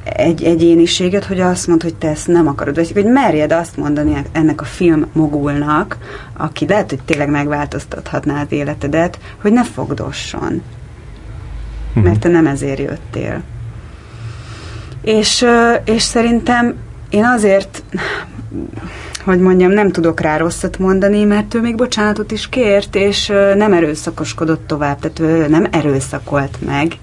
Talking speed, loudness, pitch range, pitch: 135 wpm, -14 LUFS, 145-200 Hz, 165 Hz